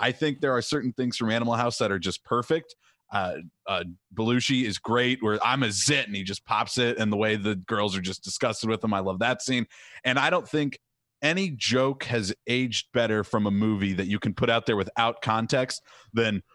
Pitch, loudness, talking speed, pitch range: 115 Hz, -26 LUFS, 225 wpm, 105-125 Hz